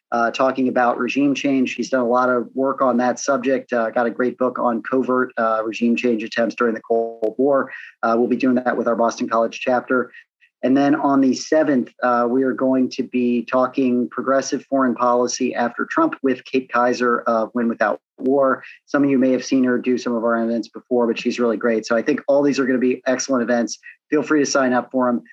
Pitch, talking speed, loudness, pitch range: 125 Hz, 235 wpm, -19 LUFS, 120-130 Hz